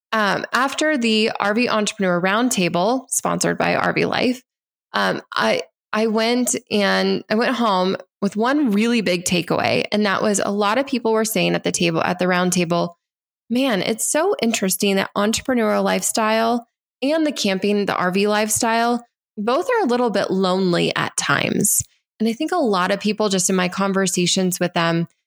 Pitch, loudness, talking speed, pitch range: 210 Hz, -19 LUFS, 170 wpm, 190-235 Hz